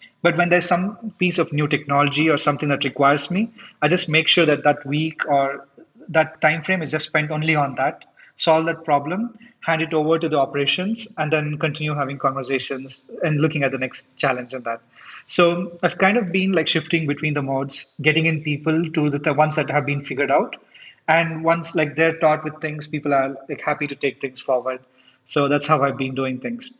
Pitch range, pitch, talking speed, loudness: 140-165 Hz, 155 Hz, 215 wpm, -20 LUFS